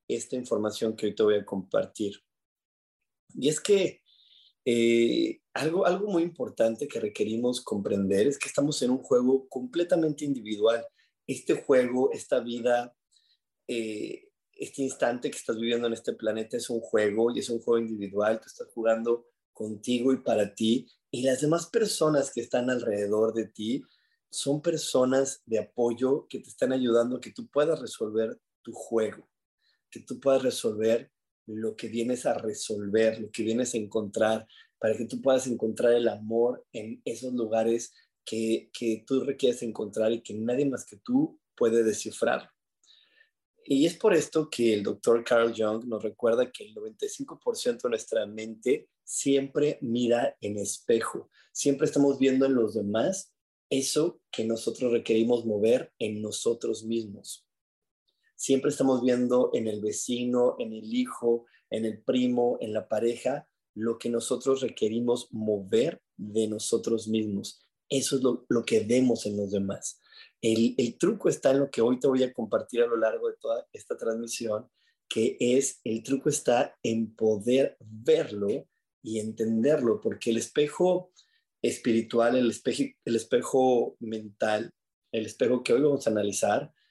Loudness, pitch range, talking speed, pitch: -28 LUFS, 110-140 Hz, 155 wpm, 120 Hz